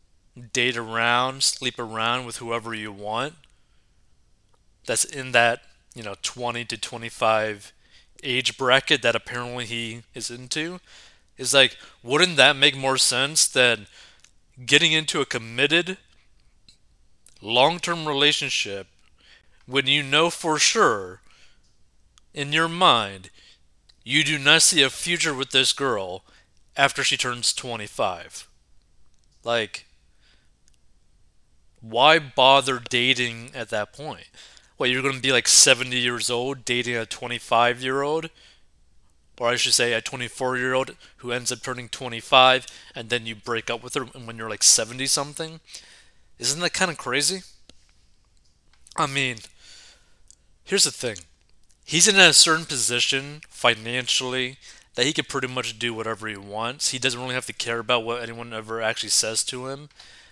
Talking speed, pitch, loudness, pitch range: 145 wpm, 125 Hz, -21 LUFS, 115-140 Hz